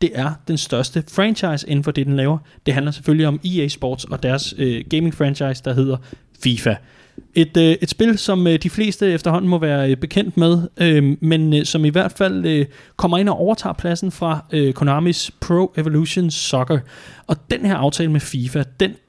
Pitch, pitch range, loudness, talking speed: 155 Hz, 140-175 Hz, -18 LUFS, 175 wpm